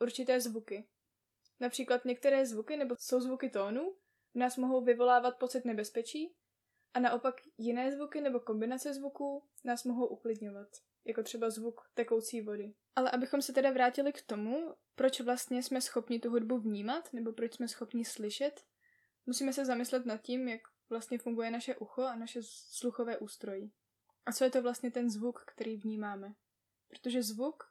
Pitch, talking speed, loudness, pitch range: 245 Hz, 160 wpm, -36 LUFS, 230-260 Hz